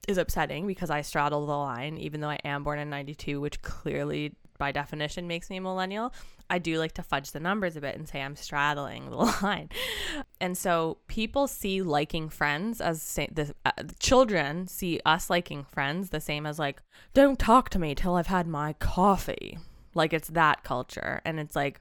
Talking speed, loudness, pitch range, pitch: 195 wpm, -29 LUFS, 145-185 Hz, 160 Hz